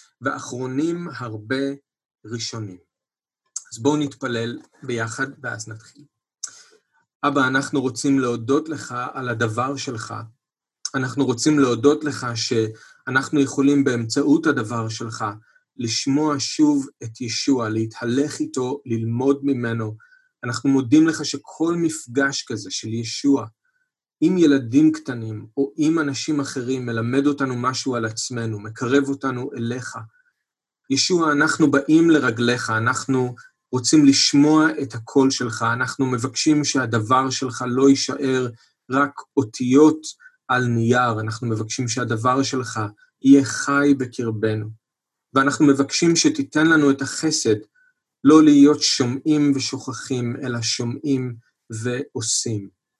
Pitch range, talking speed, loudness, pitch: 120-145 Hz, 110 wpm, -20 LUFS, 135 Hz